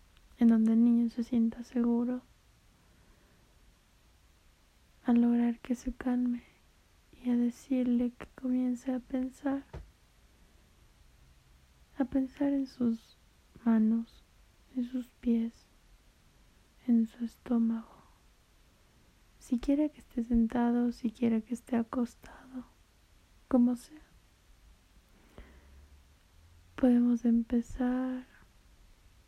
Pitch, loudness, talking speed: 235 Hz, -31 LUFS, 85 wpm